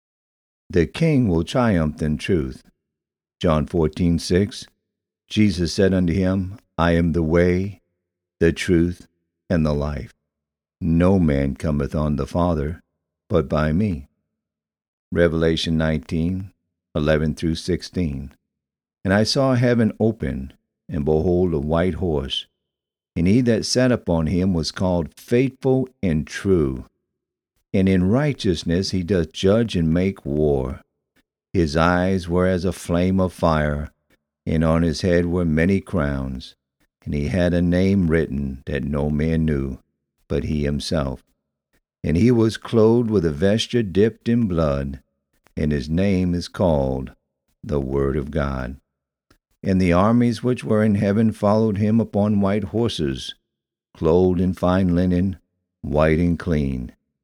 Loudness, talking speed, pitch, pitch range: -21 LUFS, 140 wpm, 85 Hz, 75-95 Hz